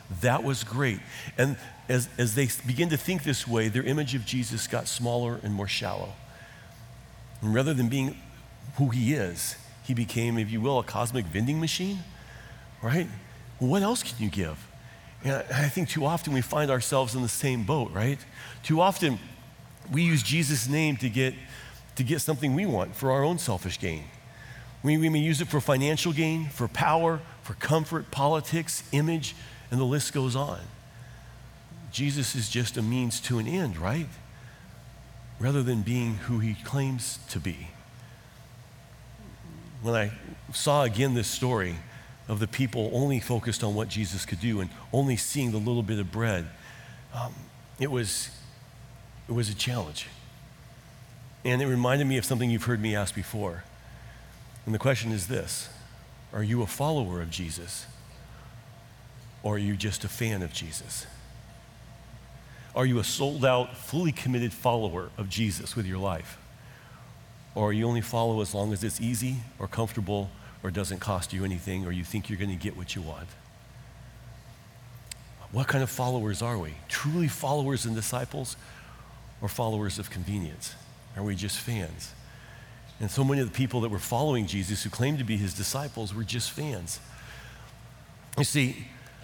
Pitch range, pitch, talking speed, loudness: 110-135 Hz, 120 Hz, 170 wpm, -29 LUFS